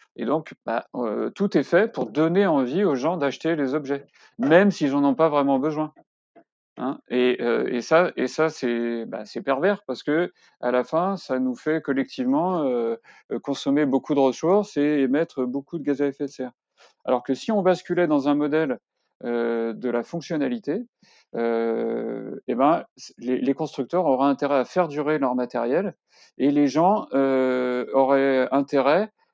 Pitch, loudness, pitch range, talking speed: 140 Hz, -23 LUFS, 130-165 Hz, 180 wpm